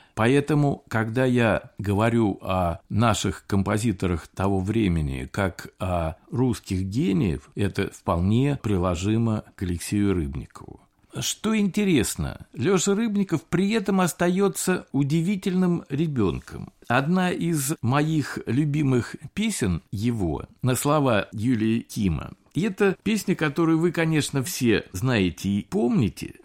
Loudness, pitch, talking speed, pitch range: -24 LUFS, 120 Hz, 110 wpm, 100-165 Hz